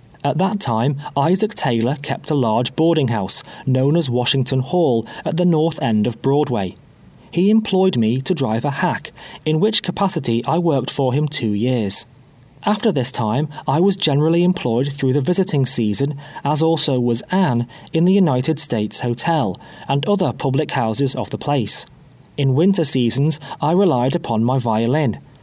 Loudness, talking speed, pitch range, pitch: -18 LUFS, 170 wpm, 125-165 Hz, 140 Hz